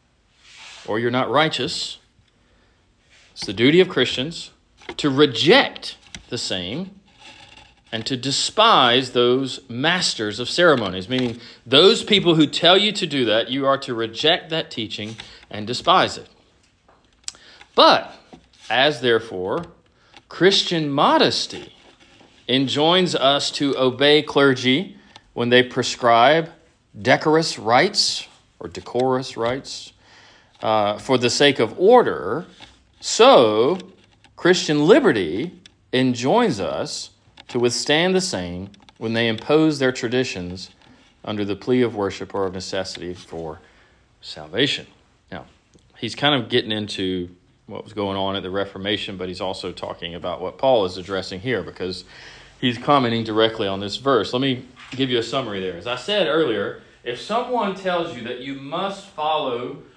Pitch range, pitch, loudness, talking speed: 105-150 Hz, 125 Hz, -19 LUFS, 135 wpm